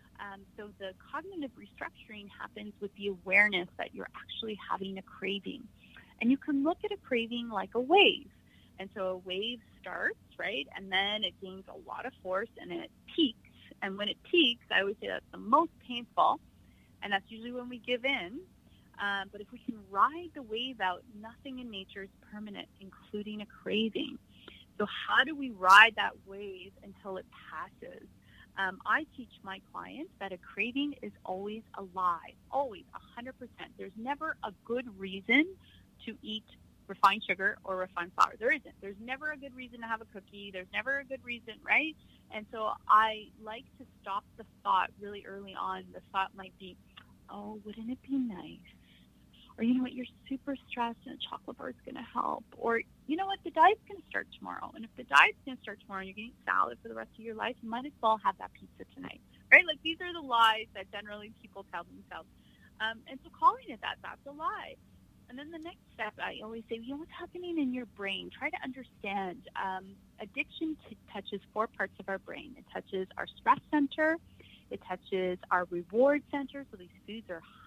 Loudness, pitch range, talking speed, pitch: -32 LUFS, 195-265 Hz, 205 wpm, 220 Hz